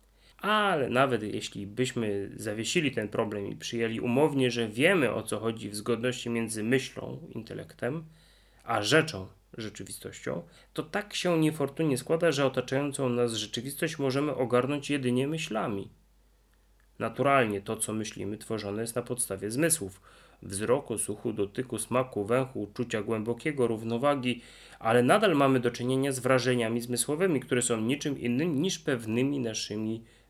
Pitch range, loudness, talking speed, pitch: 110-135 Hz, -29 LUFS, 135 wpm, 120 Hz